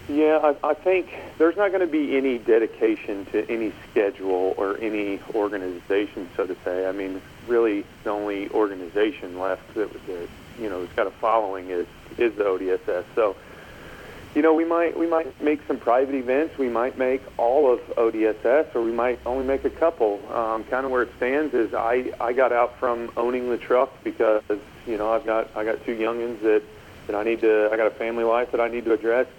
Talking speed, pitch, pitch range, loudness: 210 wpm, 120 Hz, 110-150 Hz, -24 LUFS